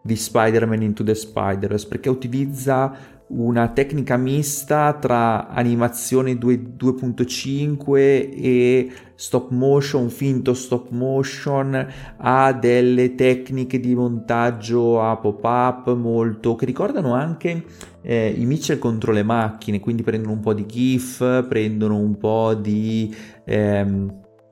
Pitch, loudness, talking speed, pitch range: 125 Hz, -20 LUFS, 120 wpm, 110-130 Hz